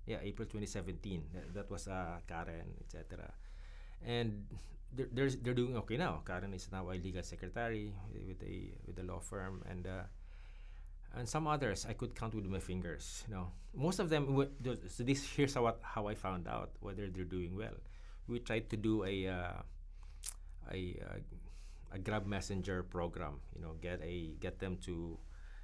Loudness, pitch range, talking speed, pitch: -42 LUFS, 85-110 Hz, 180 wpm, 95 Hz